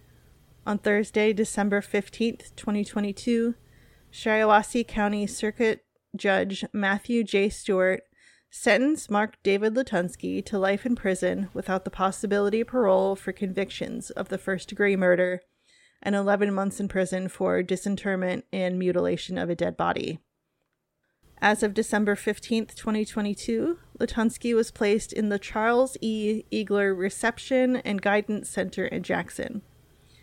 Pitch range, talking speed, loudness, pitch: 195-220 Hz, 125 wpm, -26 LUFS, 205 Hz